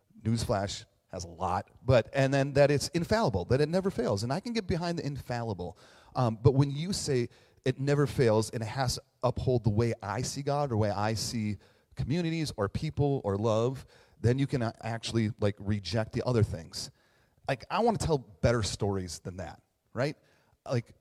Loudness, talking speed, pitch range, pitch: -30 LUFS, 195 wpm, 105-140 Hz, 120 Hz